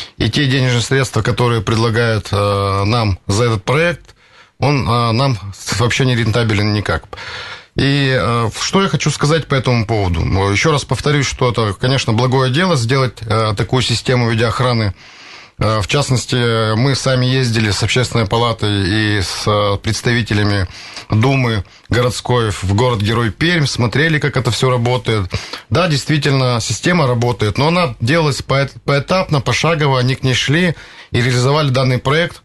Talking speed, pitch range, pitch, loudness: 135 wpm, 110-135 Hz, 120 Hz, -15 LUFS